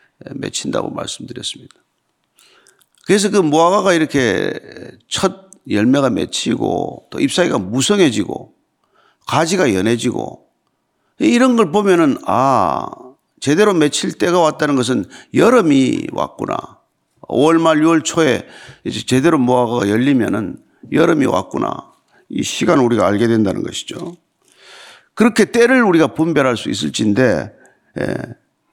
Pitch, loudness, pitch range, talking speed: 170 Hz, -15 LUFS, 140-210 Hz, 265 characters per minute